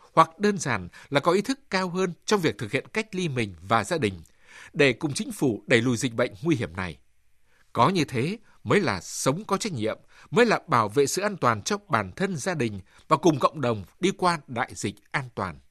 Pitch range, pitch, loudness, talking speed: 115-185 Hz, 140 Hz, -26 LUFS, 235 wpm